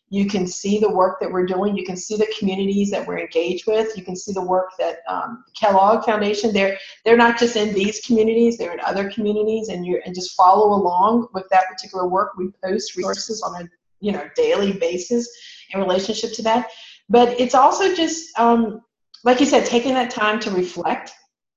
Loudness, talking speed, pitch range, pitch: -19 LUFS, 205 wpm, 190-230 Hz, 210 Hz